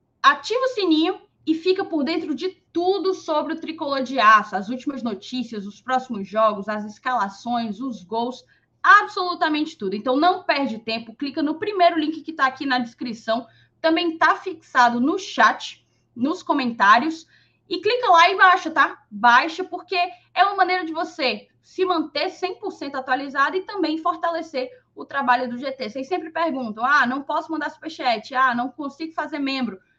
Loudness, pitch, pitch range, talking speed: -21 LUFS, 300 Hz, 250-350 Hz, 165 wpm